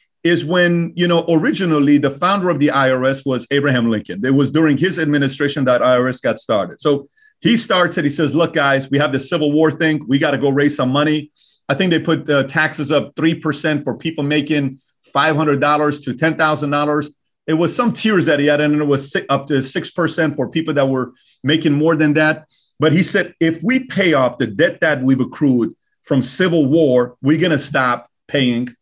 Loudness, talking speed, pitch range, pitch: -16 LUFS, 215 wpm, 140-165 Hz, 150 Hz